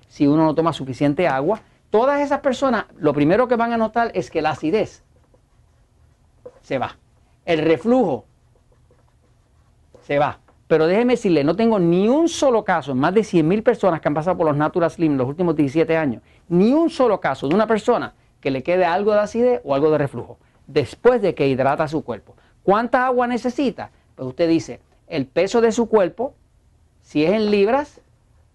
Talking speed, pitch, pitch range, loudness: 185 wpm, 170 Hz, 145-235 Hz, -19 LUFS